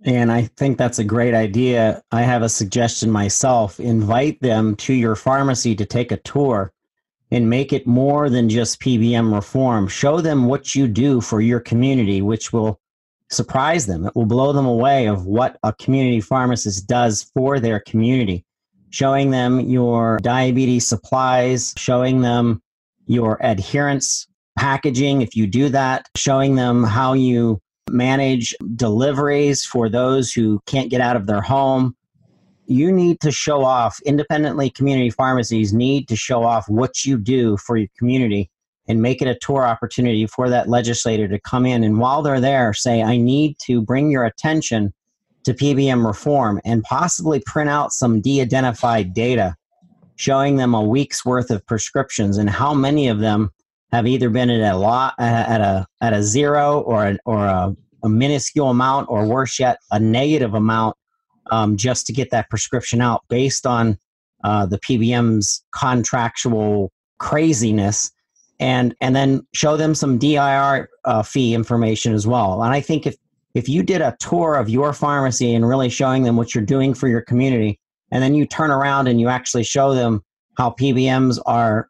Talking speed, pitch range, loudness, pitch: 170 wpm, 110-135 Hz, -18 LUFS, 125 Hz